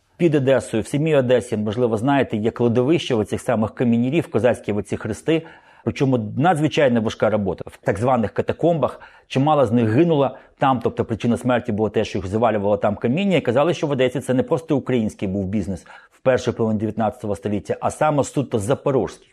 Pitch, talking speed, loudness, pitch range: 120 Hz, 185 wpm, -20 LUFS, 110-135 Hz